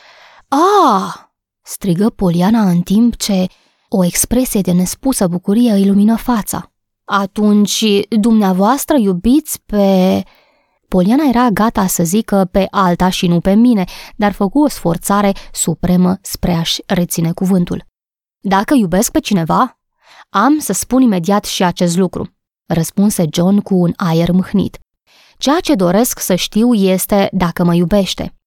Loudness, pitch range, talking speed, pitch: -13 LUFS, 180-225 Hz, 135 wpm, 200 Hz